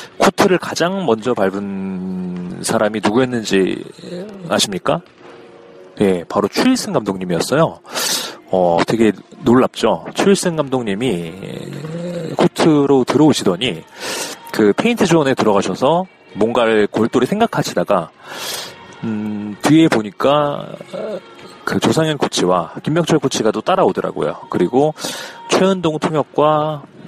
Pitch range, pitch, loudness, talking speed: 105-165 Hz, 130 Hz, -16 LUFS, 260 characters per minute